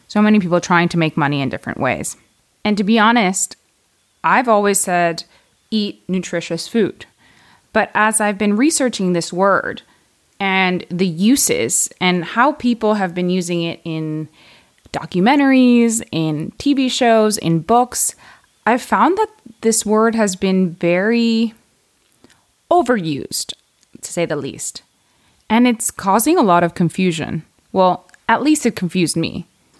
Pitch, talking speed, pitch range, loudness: 195 Hz, 140 wpm, 175-230 Hz, -16 LUFS